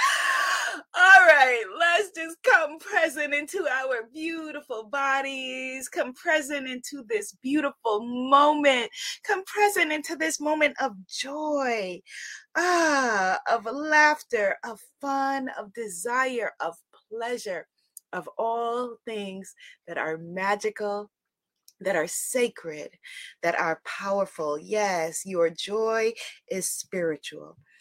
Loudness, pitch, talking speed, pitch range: -25 LUFS, 260 Hz, 105 wpm, 210-305 Hz